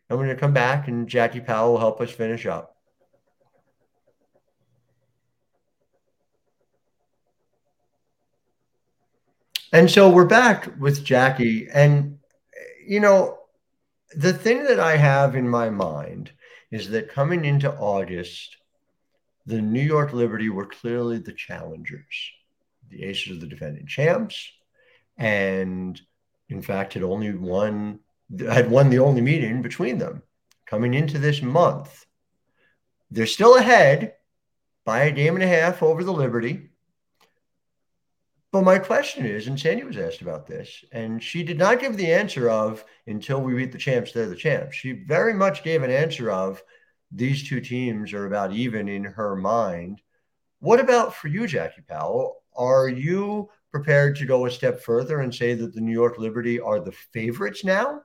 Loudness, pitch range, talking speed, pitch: -21 LUFS, 115-165 Hz, 150 wpm, 130 Hz